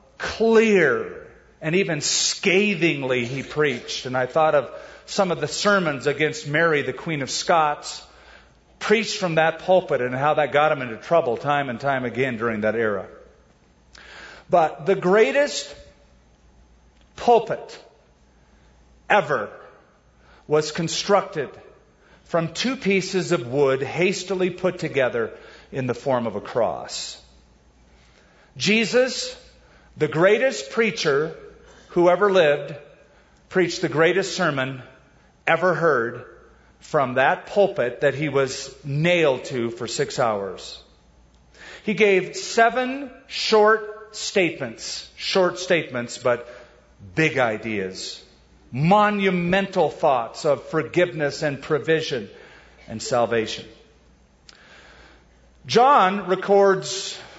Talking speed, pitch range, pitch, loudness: 110 wpm, 120-195 Hz, 155 Hz, -21 LUFS